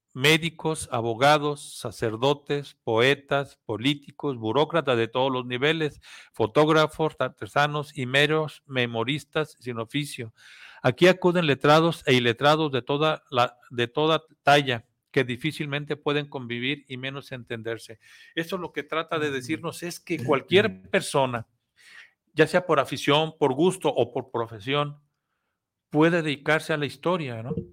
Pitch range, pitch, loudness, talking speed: 130-155 Hz, 145 Hz, -25 LUFS, 130 wpm